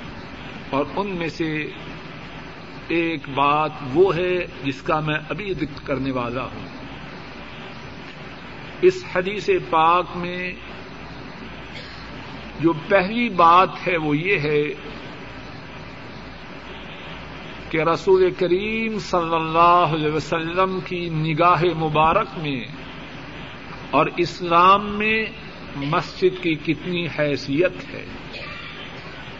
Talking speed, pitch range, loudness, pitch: 95 wpm, 155-185 Hz, -20 LUFS, 170 Hz